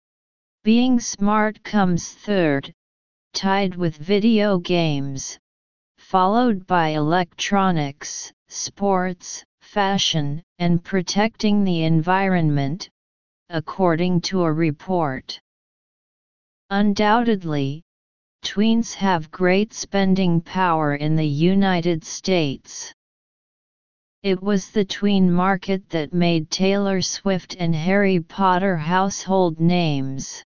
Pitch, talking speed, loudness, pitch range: 180 Hz, 90 wpm, -21 LUFS, 160-195 Hz